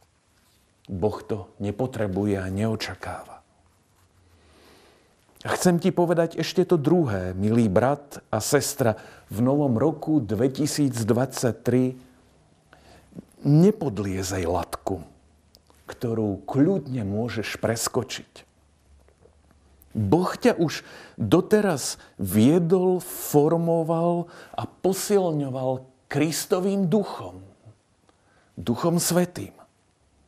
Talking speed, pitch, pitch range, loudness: 75 wpm, 120 Hz, 95-160 Hz, -24 LUFS